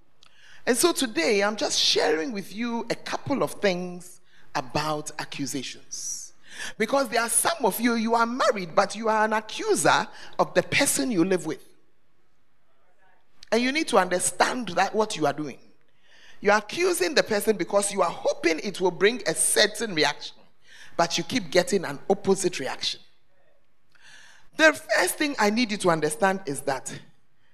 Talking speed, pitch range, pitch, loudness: 165 wpm, 170-235 Hz, 200 Hz, -24 LUFS